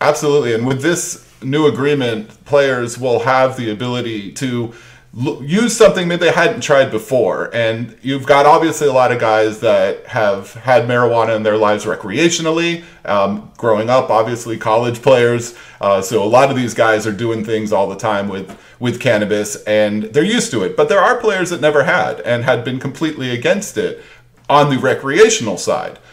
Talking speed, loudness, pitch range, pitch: 185 wpm, -15 LUFS, 110-150 Hz, 125 Hz